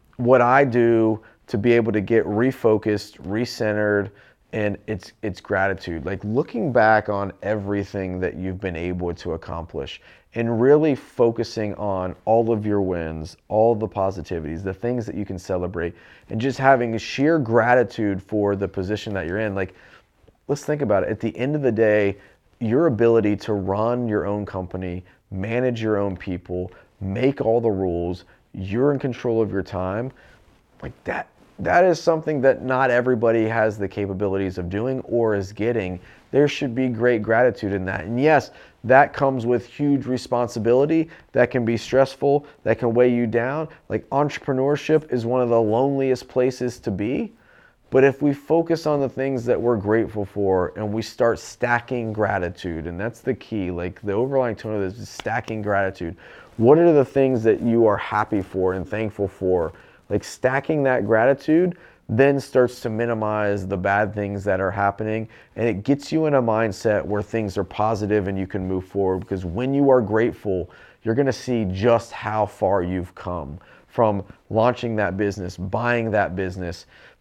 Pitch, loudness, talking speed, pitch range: 110 Hz, -22 LUFS, 175 wpm, 100-125 Hz